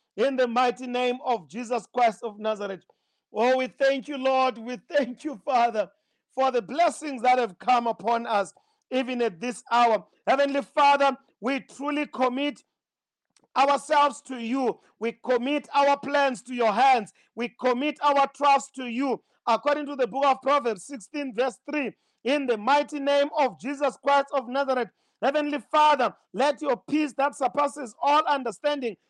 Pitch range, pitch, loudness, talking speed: 240-285 Hz, 265 Hz, -25 LUFS, 160 wpm